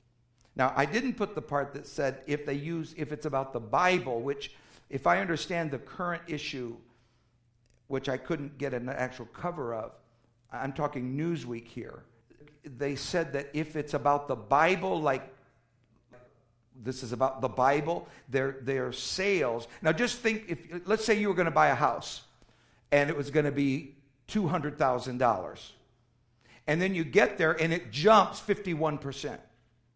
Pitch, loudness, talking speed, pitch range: 140 Hz, -30 LUFS, 160 wpm, 120-160 Hz